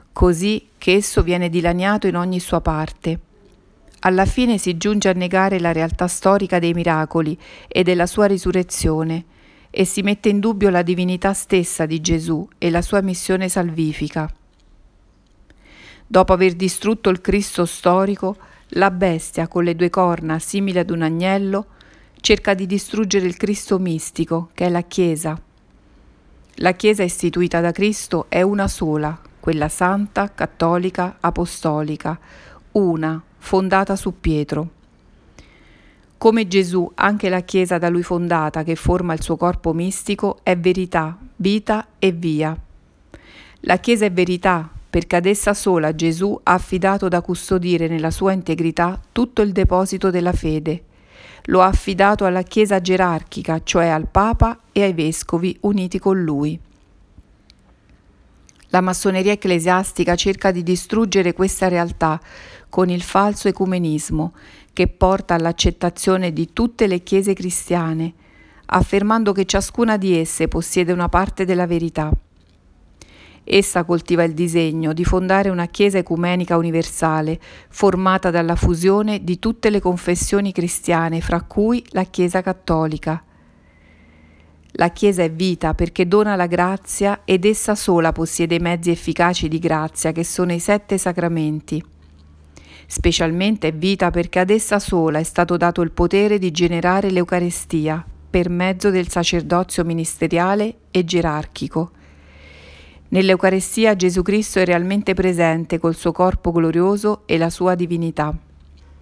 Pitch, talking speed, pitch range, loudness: 180 Hz, 135 wpm, 165-195 Hz, -18 LUFS